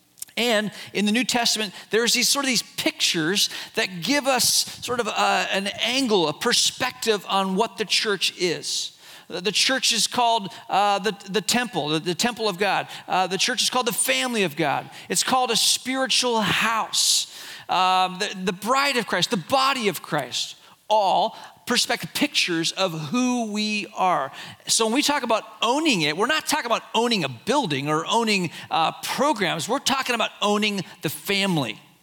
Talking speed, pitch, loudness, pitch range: 175 wpm, 220 Hz, -22 LUFS, 190-245 Hz